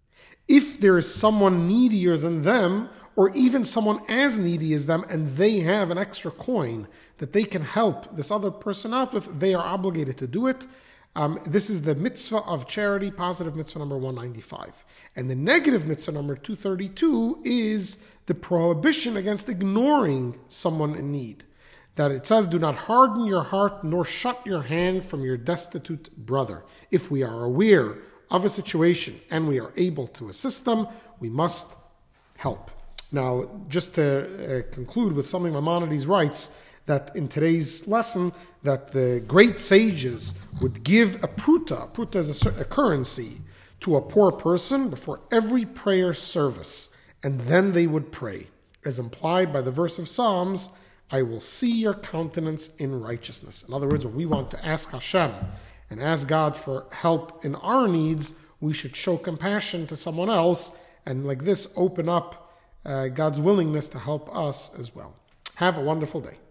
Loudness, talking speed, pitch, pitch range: -24 LUFS, 170 wpm, 170 Hz, 145-200 Hz